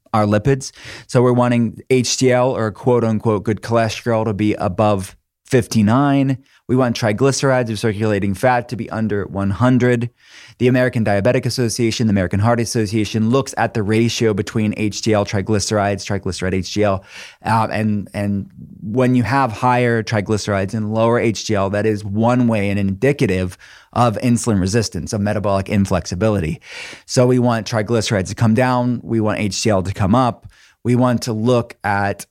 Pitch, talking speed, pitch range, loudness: 110 Hz, 155 wpm, 105-125 Hz, -18 LUFS